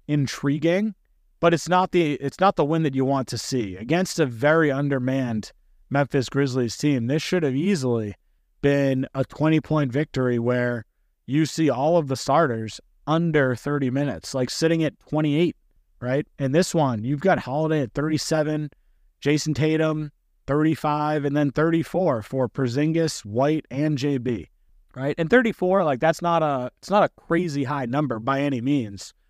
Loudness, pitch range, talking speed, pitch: -23 LUFS, 130-155 Hz, 165 wpm, 145 Hz